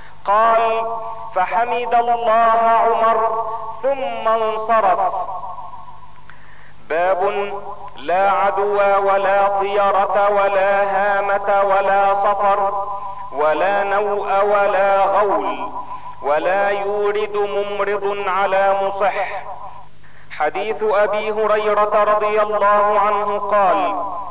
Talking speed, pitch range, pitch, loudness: 75 wpm, 200-225 Hz, 205 Hz, -17 LUFS